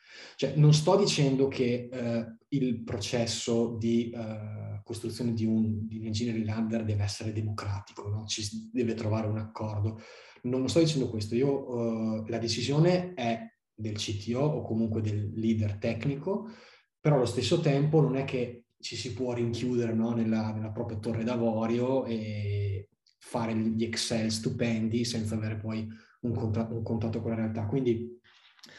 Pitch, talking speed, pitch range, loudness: 115 Hz, 155 wpm, 110-125 Hz, -30 LUFS